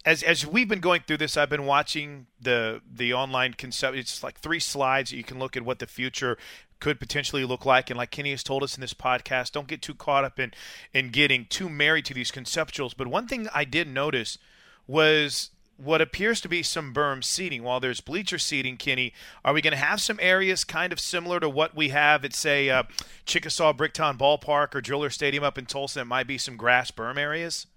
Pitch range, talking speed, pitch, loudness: 130-160 Hz, 225 wpm, 145 Hz, -25 LUFS